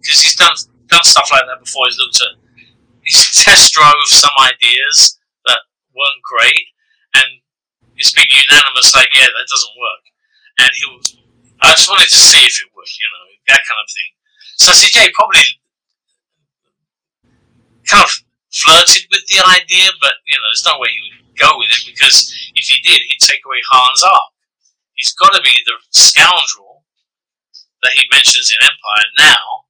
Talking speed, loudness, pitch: 180 wpm, -6 LUFS, 380 Hz